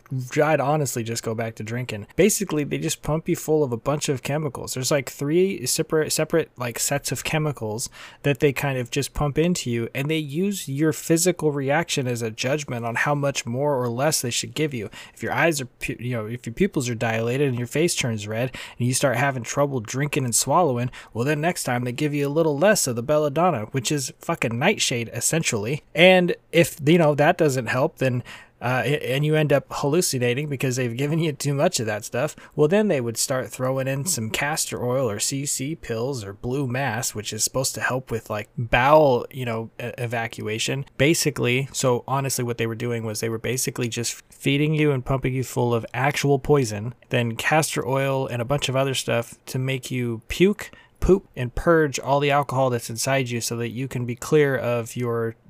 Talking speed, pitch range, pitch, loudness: 215 wpm, 120-150 Hz, 135 Hz, -23 LUFS